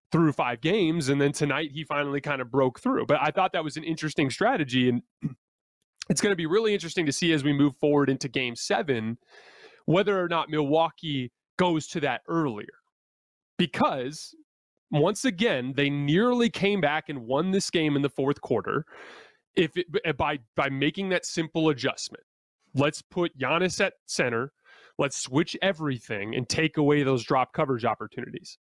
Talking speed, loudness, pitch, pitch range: 170 wpm, -26 LUFS, 150 Hz, 140-175 Hz